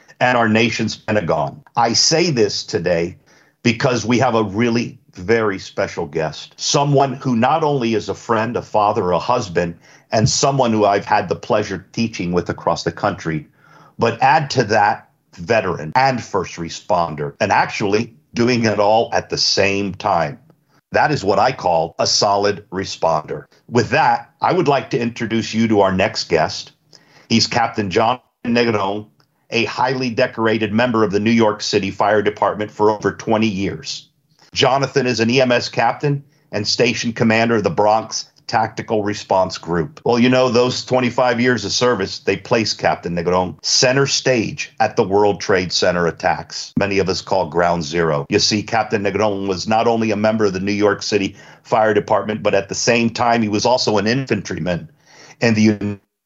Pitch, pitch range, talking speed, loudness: 110 Hz, 100-125 Hz, 175 wpm, -17 LUFS